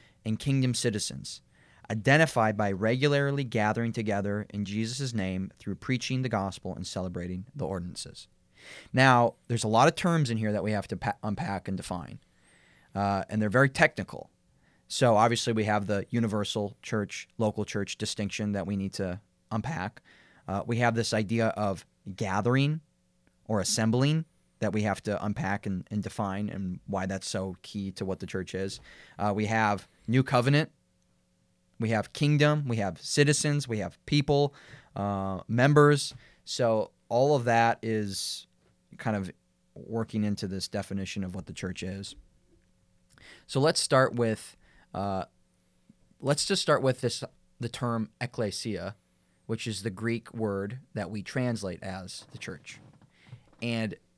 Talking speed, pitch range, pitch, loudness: 155 wpm, 100-120 Hz, 110 Hz, -29 LUFS